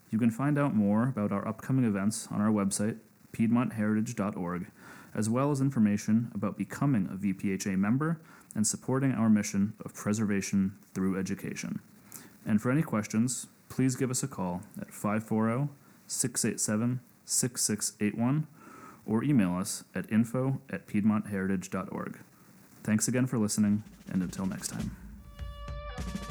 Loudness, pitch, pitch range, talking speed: -30 LUFS, 110 Hz, 105-130 Hz, 130 wpm